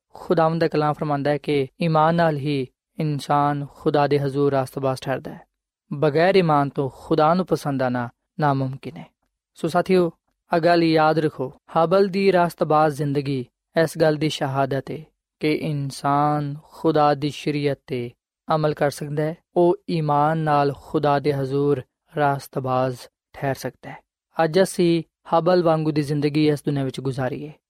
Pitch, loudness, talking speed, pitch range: 150 Hz, -22 LUFS, 150 wpm, 140-160 Hz